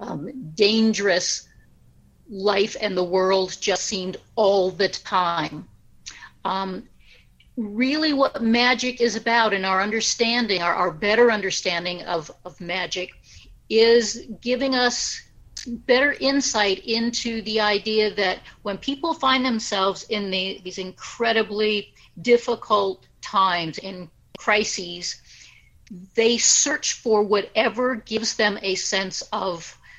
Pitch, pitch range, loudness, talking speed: 210 Hz, 190-235 Hz, -22 LUFS, 115 wpm